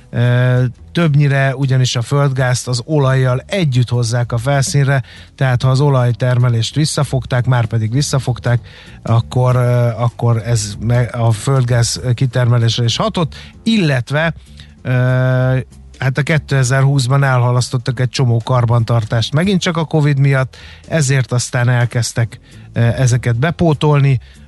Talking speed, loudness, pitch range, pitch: 110 wpm, -15 LUFS, 120-140 Hz, 125 Hz